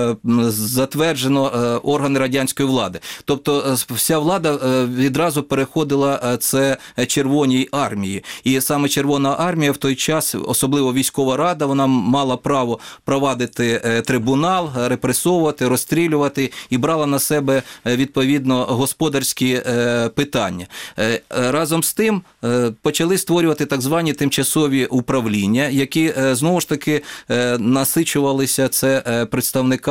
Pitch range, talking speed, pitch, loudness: 125-145 Hz, 105 wpm, 135 Hz, -18 LUFS